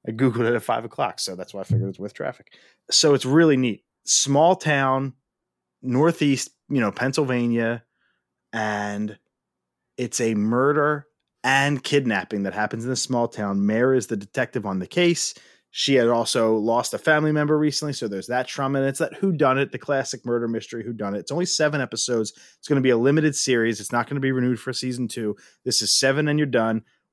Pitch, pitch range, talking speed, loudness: 125 Hz, 110-140 Hz, 210 wpm, -22 LUFS